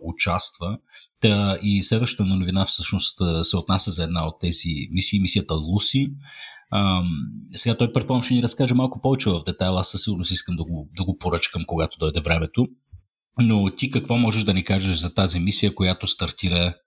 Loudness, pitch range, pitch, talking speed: -21 LUFS, 90-110 Hz, 95 Hz, 170 wpm